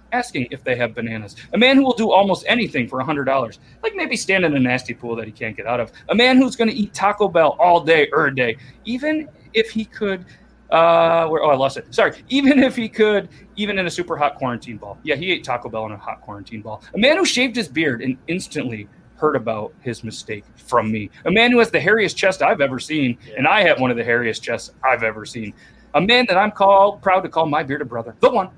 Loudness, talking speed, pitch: -18 LUFS, 255 wpm, 165 Hz